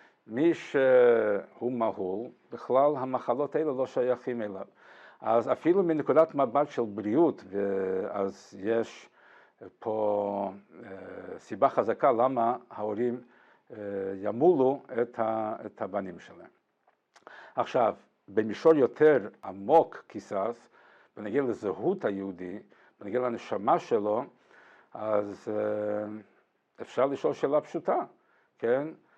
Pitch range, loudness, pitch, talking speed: 100-145 Hz, -28 LUFS, 110 Hz, 90 wpm